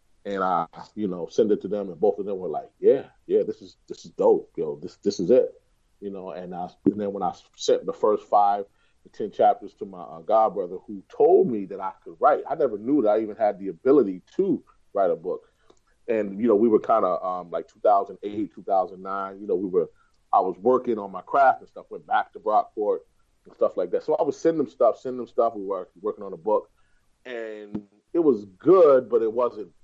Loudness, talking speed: -24 LUFS, 245 wpm